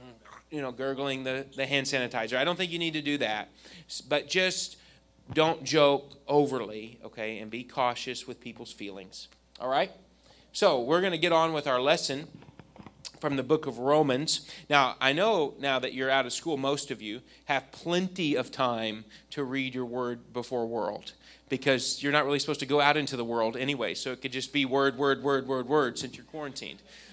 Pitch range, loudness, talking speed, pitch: 125-145 Hz, -29 LUFS, 200 wpm, 135 Hz